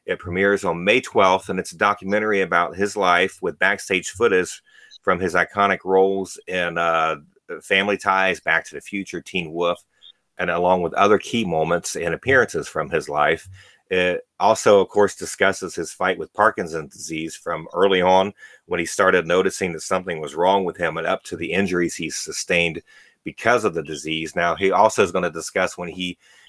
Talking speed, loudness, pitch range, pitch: 190 wpm, -21 LUFS, 85-100 Hz, 95 Hz